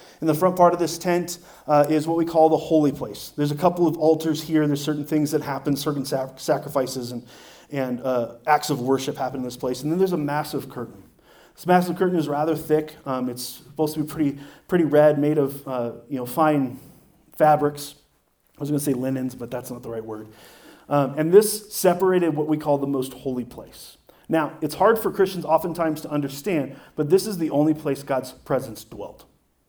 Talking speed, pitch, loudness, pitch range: 215 wpm, 150 Hz, -23 LUFS, 130-160 Hz